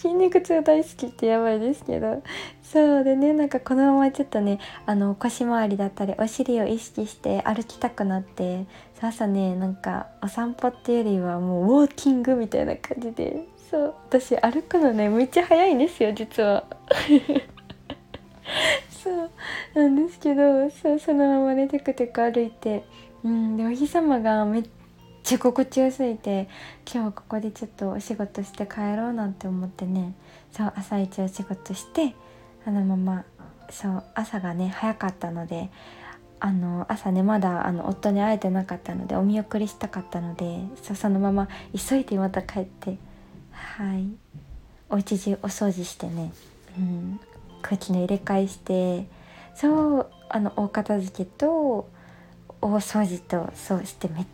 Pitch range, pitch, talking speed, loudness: 190-255 Hz, 215 Hz, 305 characters per minute, -25 LUFS